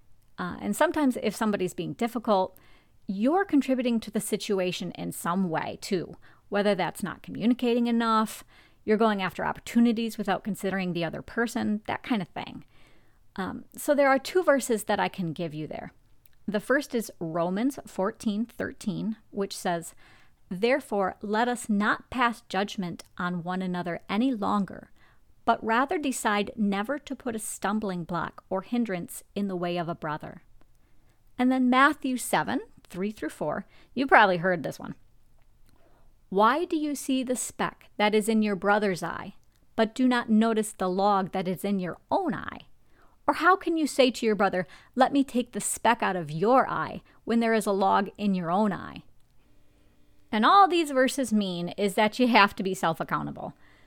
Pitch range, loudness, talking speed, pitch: 185-245 Hz, -27 LUFS, 175 wpm, 210 Hz